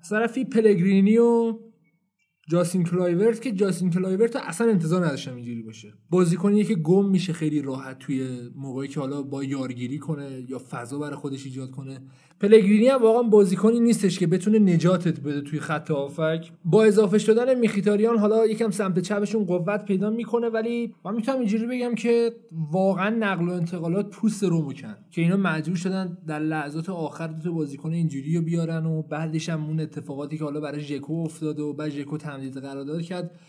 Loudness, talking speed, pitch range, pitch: -23 LUFS, 175 wpm, 150-210 Hz, 175 Hz